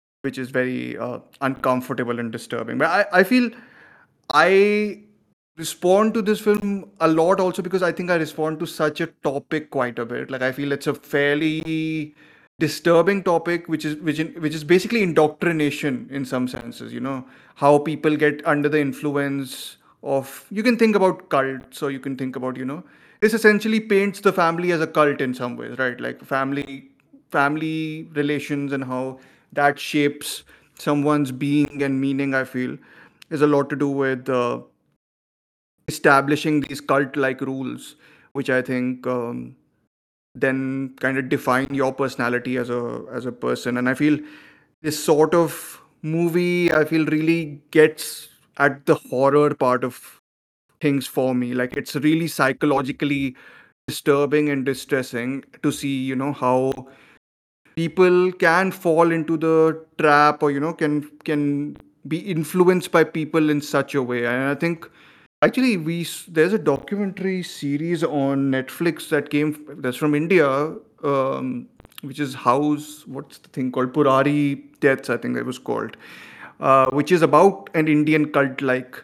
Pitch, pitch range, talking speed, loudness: 145 Hz, 135-160 Hz, 160 wpm, -21 LUFS